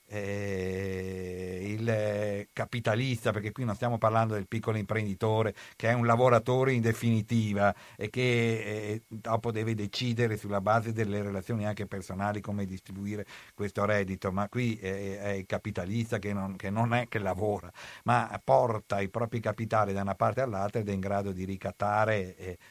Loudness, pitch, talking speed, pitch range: -31 LUFS, 105 Hz, 165 wpm, 100-115 Hz